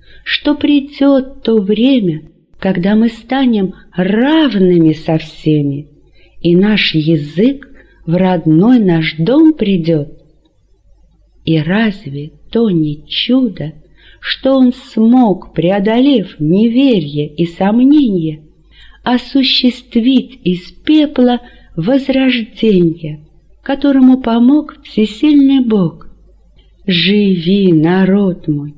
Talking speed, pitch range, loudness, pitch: 85 wpm, 165-250 Hz, -12 LUFS, 195 Hz